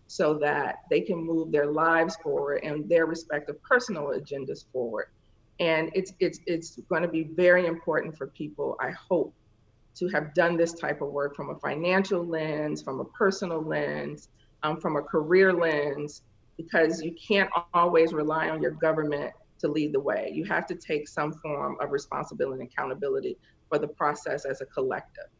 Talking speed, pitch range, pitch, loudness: 175 wpm, 150-180 Hz, 160 Hz, -28 LUFS